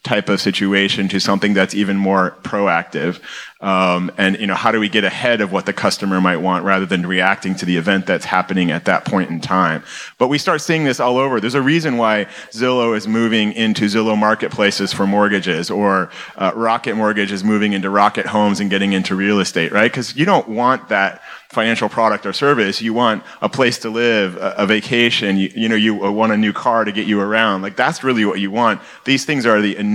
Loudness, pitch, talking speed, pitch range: -16 LUFS, 105 Hz, 220 wpm, 95-115 Hz